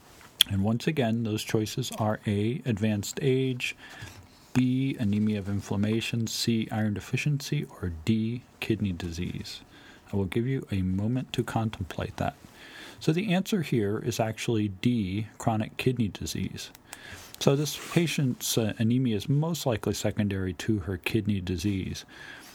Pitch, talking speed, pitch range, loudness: 110 Hz, 140 wpm, 105-125 Hz, -29 LUFS